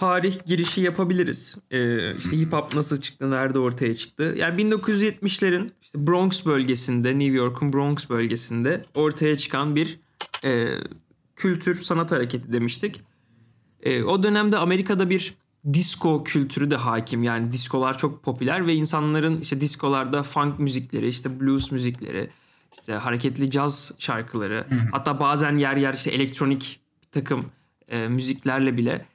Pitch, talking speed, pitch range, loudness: 140 Hz, 135 wpm, 125-160 Hz, -24 LUFS